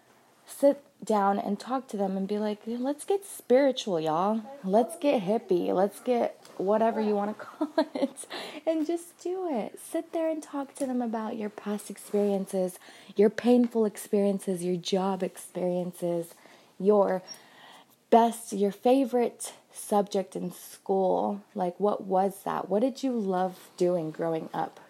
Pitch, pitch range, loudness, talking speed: 210 Hz, 190-255 Hz, -28 LUFS, 150 wpm